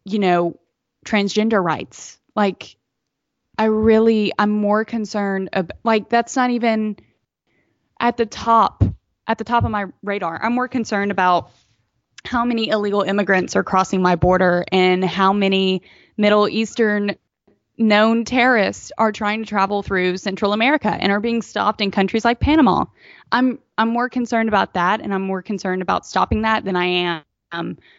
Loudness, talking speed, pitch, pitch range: -18 LUFS, 160 wpm, 205 Hz, 190-225 Hz